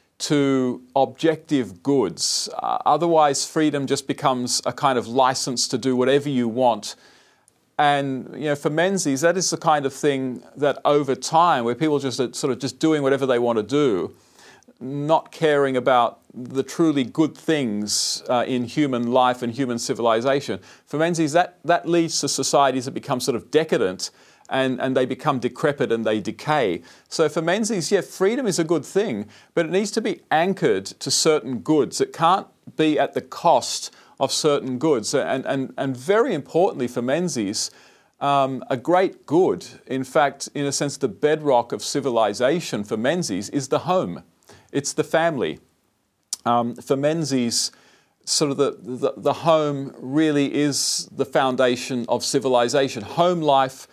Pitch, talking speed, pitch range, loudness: 140 Hz, 165 wpm, 130-160 Hz, -21 LUFS